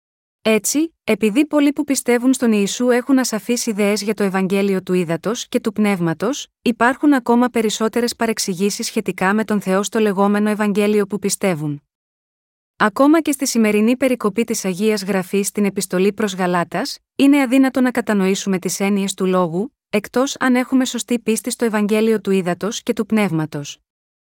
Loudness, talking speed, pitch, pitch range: -18 LUFS, 155 wpm, 215 Hz, 195-240 Hz